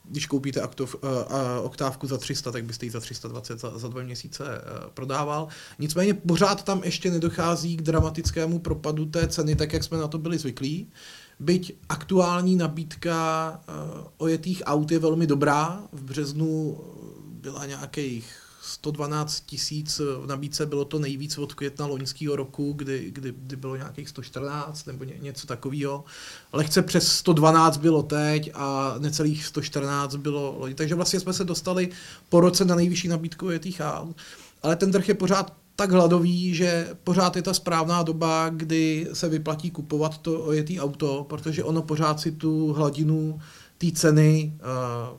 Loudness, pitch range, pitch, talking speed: -25 LUFS, 140-170 Hz, 155 Hz, 150 wpm